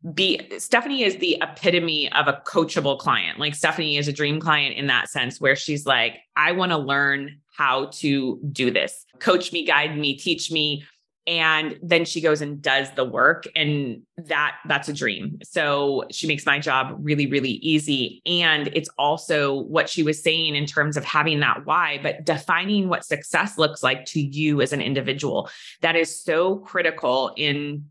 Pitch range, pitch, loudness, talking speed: 140-165 Hz, 150 Hz, -22 LUFS, 185 wpm